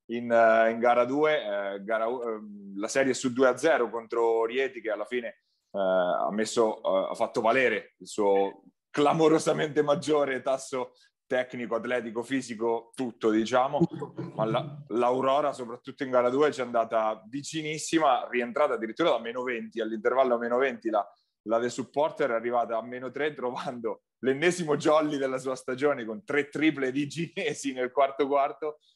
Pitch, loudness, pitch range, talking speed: 125 Hz, -27 LUFS, 115-145 Hz, 155 wpm